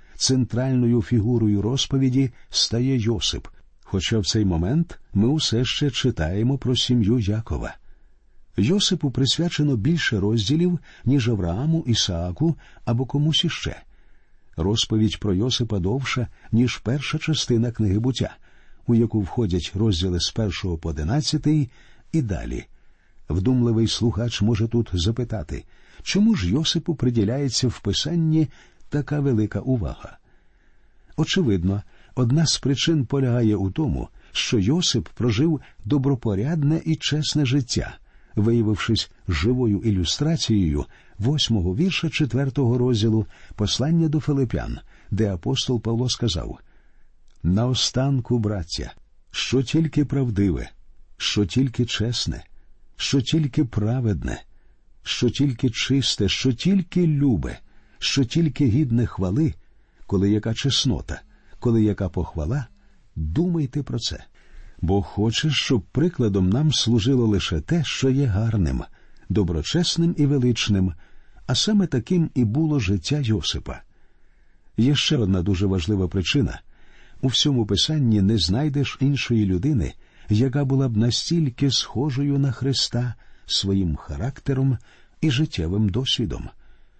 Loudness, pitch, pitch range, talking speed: -22 LUFS, 120 Hz, 105-140 Hz, 110 wpm